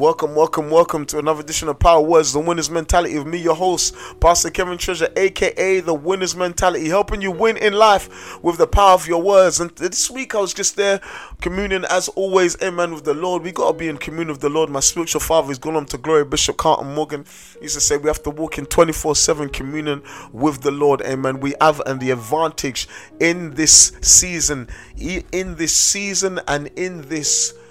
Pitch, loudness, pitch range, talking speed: 165 Hz, -17 LUFS, 150-185 Hz, 205 wpm